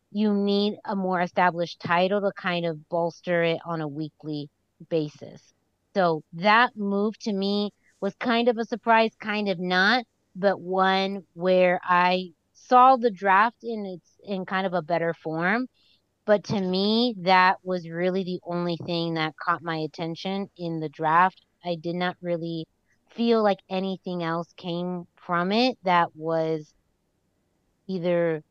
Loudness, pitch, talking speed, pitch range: -25 LUFS, 180 Hz, 155 wpm, 170-200 Hz